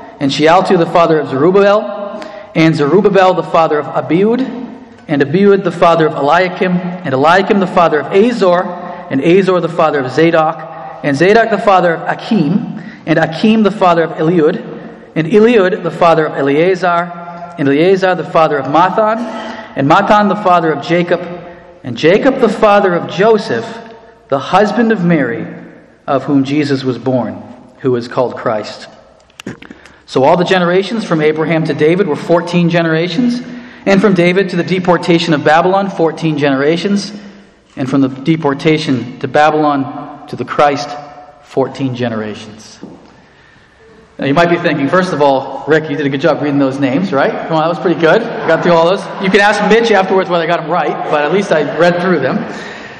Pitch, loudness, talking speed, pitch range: 170 Hz, -12 LUFS, 175 wpm, 150-200 Hz